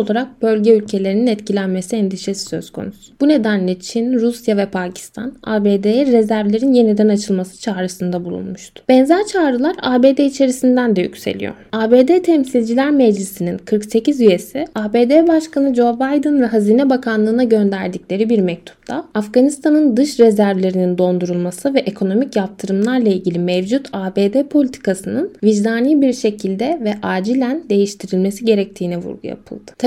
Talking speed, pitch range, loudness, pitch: 120 wpm, 195-260 Hz, -15 LUFS, 220 Hz